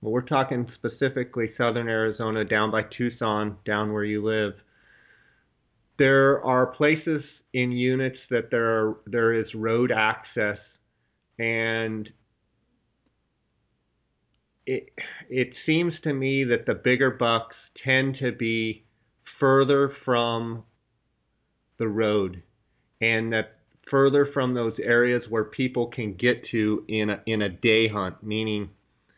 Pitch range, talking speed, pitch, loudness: 110-125 Hz, 125 wpm, 115 Hz, -25 LUFS